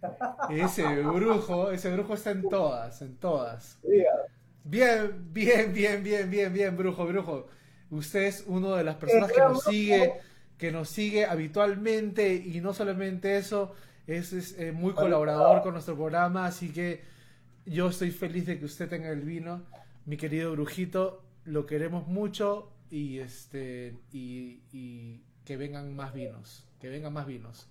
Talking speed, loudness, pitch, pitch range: 150 wpm, -29 LUFS, 175 Hz, 145-200 Hz